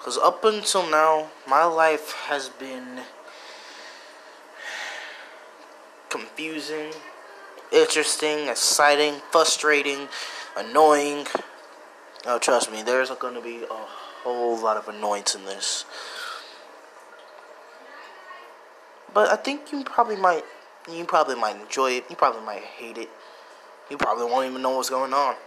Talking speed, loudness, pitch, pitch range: 120 wpm, -23 LUFS, 150 Hz, 130-185 Hz